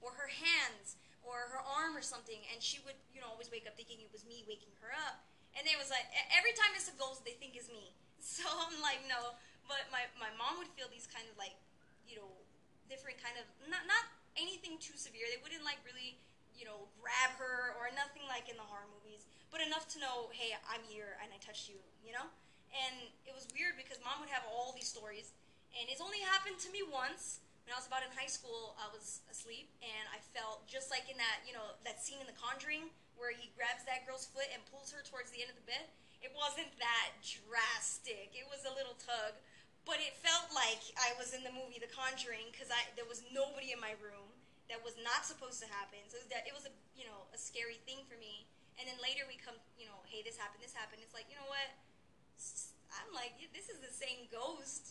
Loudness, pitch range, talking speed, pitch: -41 LUFS, 230-275 Hz, 235 wpm, 250 Hz